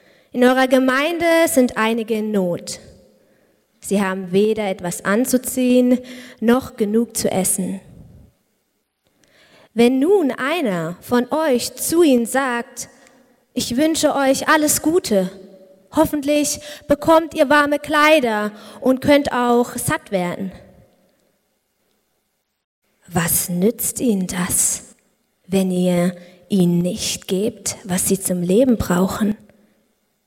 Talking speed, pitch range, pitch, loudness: 105 wpm, 190-260 Hz, 230 Hz, -18 LUFS